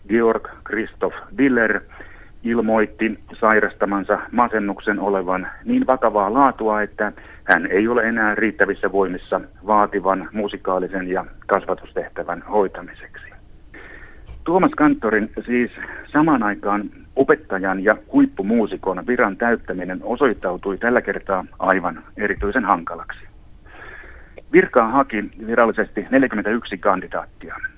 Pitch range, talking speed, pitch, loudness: 100-120 Hz, 95 wpm, 110 Hz, -20 LUFS